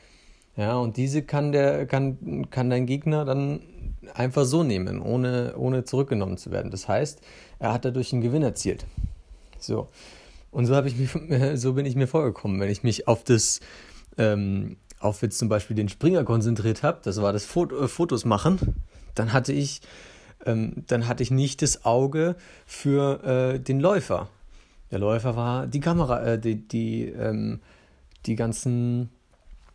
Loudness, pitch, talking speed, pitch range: -25 LUFS, 120 Hz, 165 wpm, 105-135 Hz